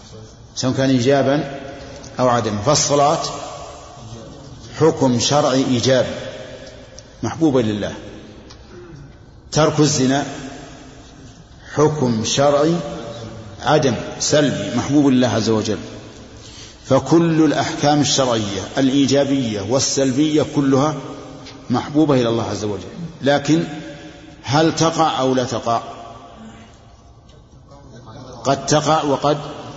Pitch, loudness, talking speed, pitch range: 135 Hz, -17 LUFS, 85 wpm, 115-145 Hz